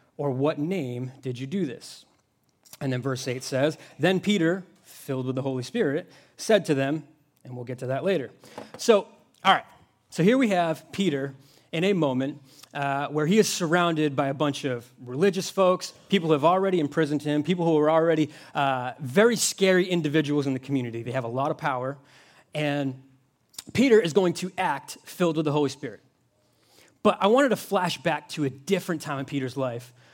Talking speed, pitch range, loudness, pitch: 195 wpm, 135-175 Hz, -25 LUFS, 150 Hz